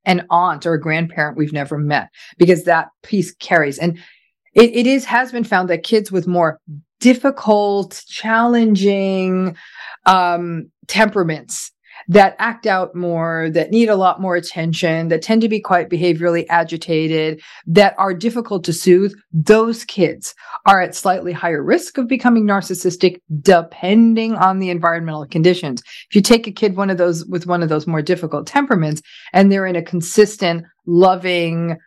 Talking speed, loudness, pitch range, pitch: 160 wpm, -16 LUFS, 170-205 Hz, 180 Hz